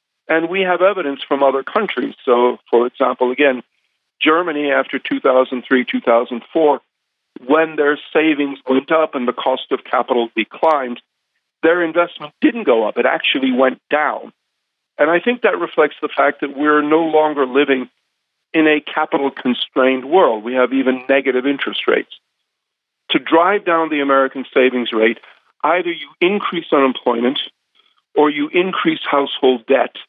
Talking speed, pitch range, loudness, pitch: 150 wpm, 130-160 Hz, -16 LUFS, 140 Hz